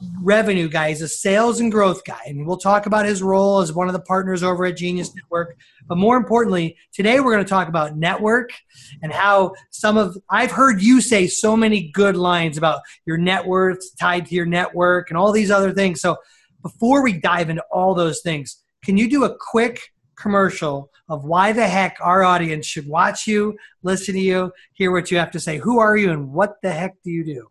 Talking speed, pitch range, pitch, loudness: 220 wpm, 170-205 Hz, 185 Hz, -18 LUFS